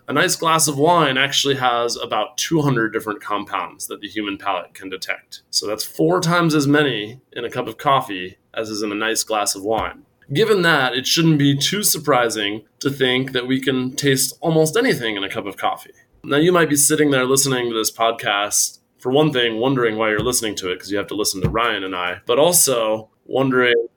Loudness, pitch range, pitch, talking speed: -18 LUFS, 110-145 Hz, 125 Hz, 220 wpm